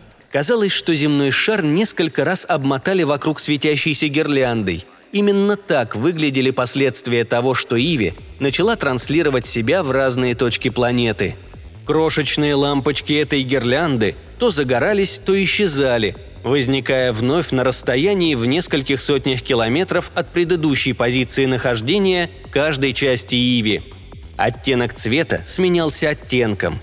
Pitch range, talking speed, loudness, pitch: 125-155 Hz, 115 wpm, -17 LUFS, 135 Hz